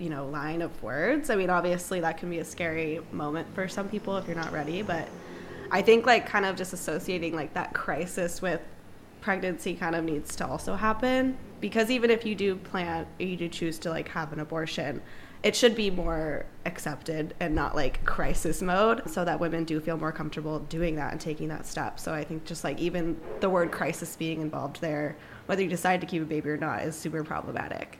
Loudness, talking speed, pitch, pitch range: -29 LUFS, 220 wpm, 165 Hz, 155-185 Hz